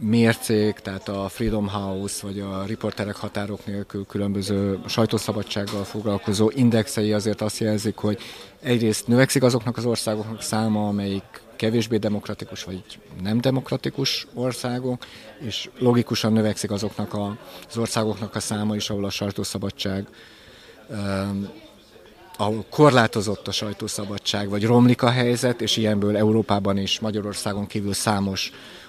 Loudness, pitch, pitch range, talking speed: -23 LUFS, 105 Hz, 100-115 Hz, 120 wpm